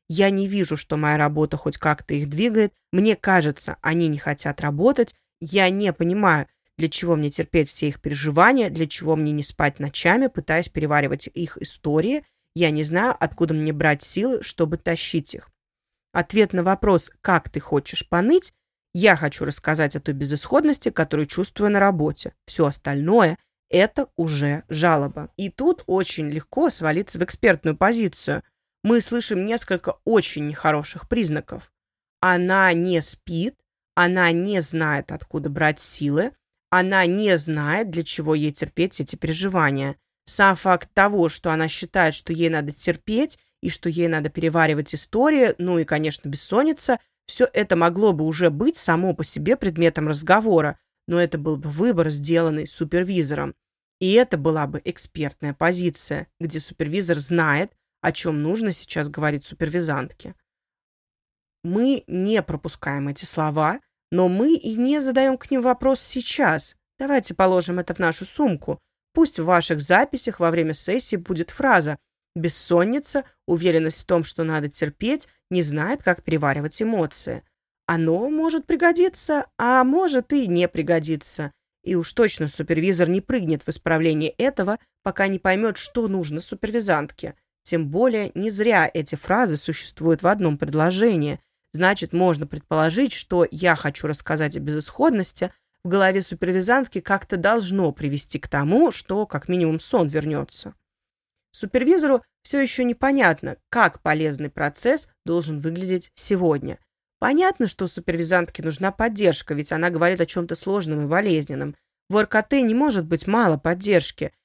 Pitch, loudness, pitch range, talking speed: 175 Hz, -21 LUFS, 155-205 Hz, 145 wpm